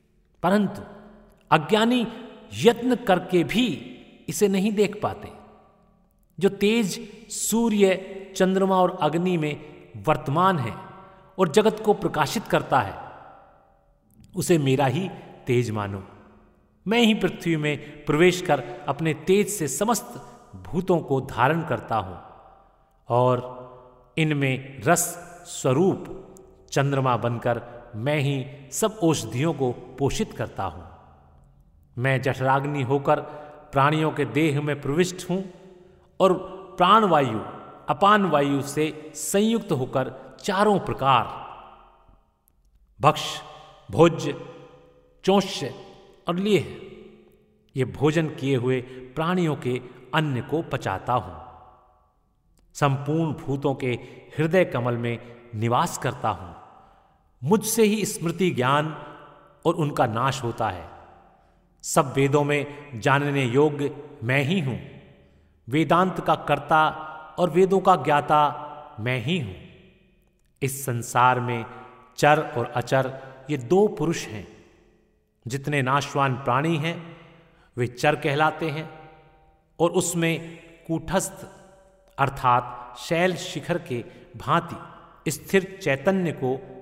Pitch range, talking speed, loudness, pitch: 125-180 Hz, 110 wpm, -24 LUFS, 150 Hz